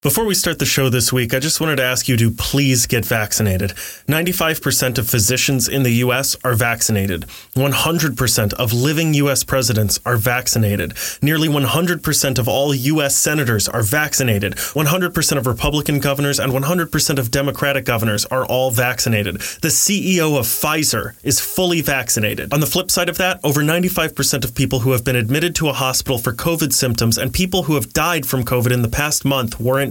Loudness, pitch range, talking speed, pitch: -16 LUFS, 120-155 Hz, 185 wpm, 135 Hz